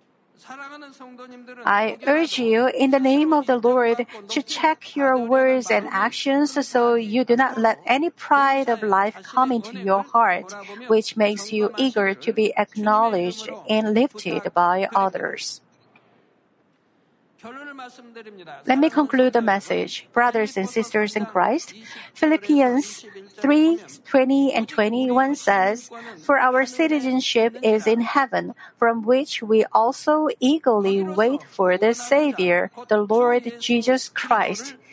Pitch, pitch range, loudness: 240 Hz, 215-270 Hz, -20 LUFS